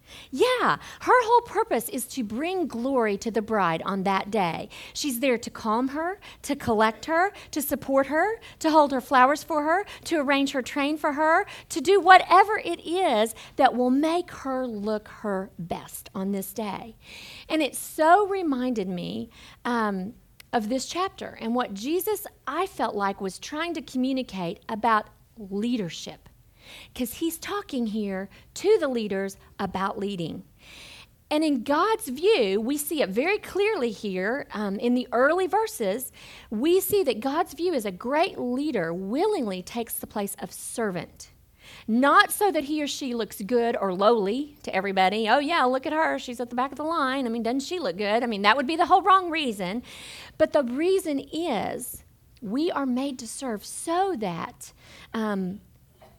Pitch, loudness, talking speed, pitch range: 260 Hz, -25 LUFS, 175 wpm, 220-330 Hz